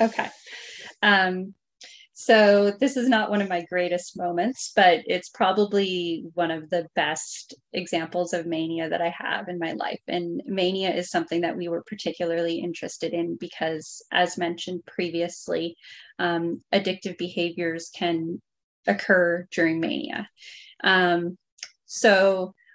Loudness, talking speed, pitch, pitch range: -25 LUFS, 130 wpm, 175 Hz, 170-195 Hz